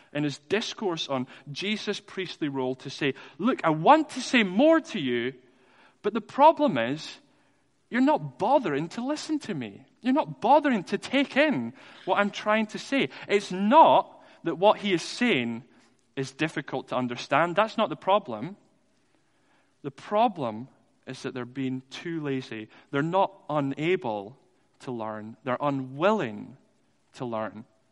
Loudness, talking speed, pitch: -26 LUFS, 155 wpm, 175 Hz